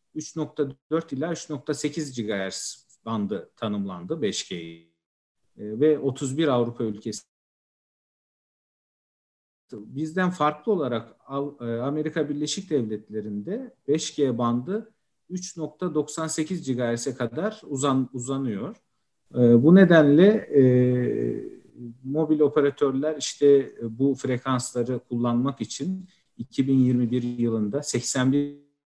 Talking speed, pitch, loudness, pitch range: 80 wpm, 140 Hz, -24 LUFS, 120-155 Hz